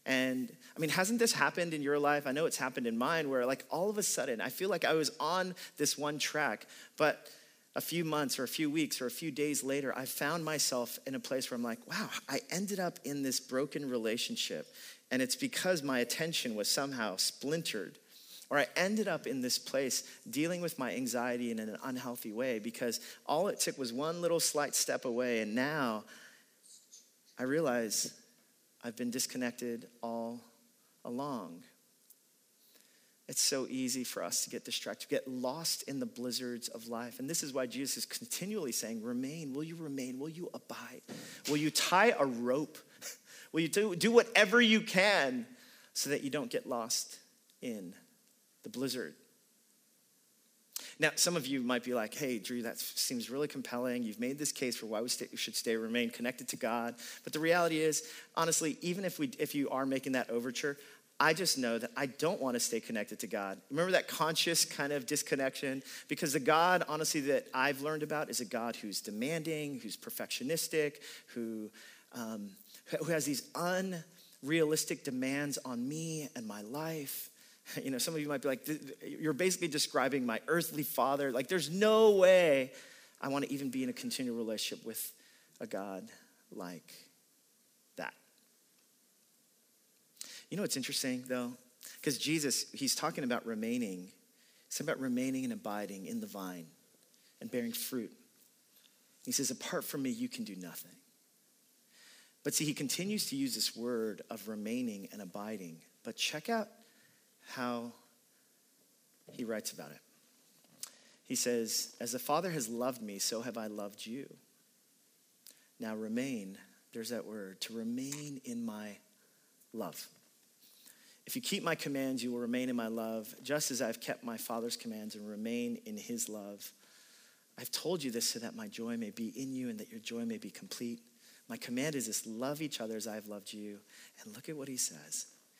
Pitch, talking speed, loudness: 150 Hz, 180 wpm, -35 LUFS